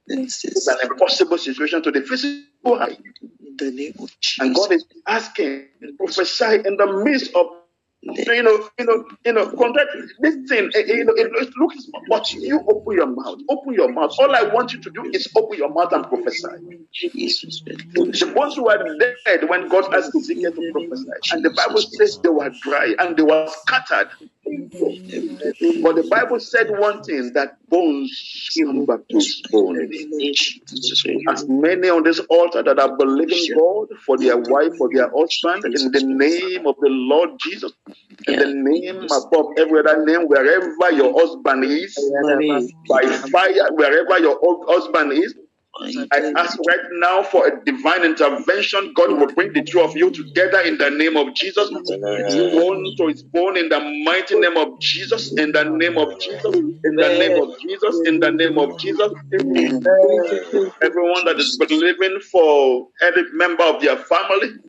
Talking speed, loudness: 170 wpm, -18 LUFS